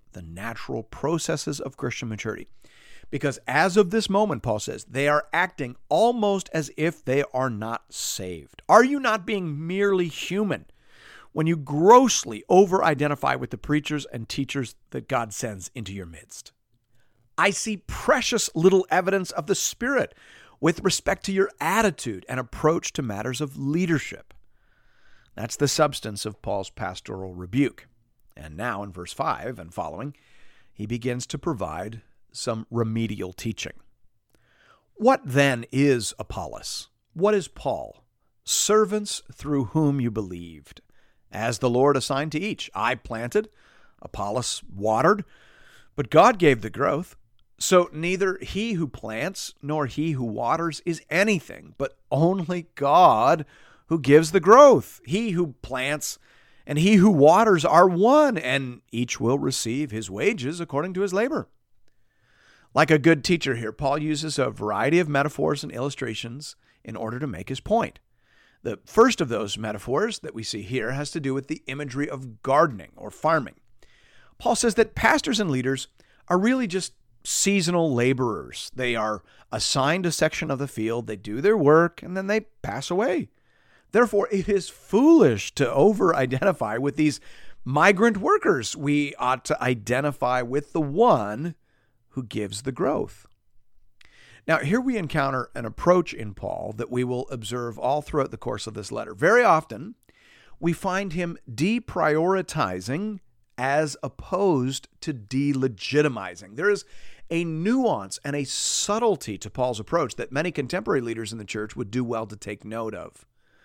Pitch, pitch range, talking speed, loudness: 140 Hz, 115-175 Hz, 155 wpm, -23 LUFS